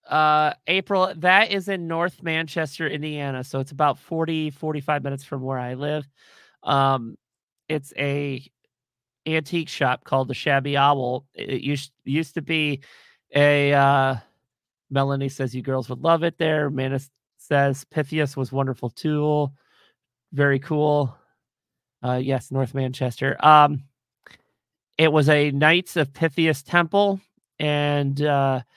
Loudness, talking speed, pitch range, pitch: -22 LUFS, 135 wpm, 135-155 Hz, 145 Hz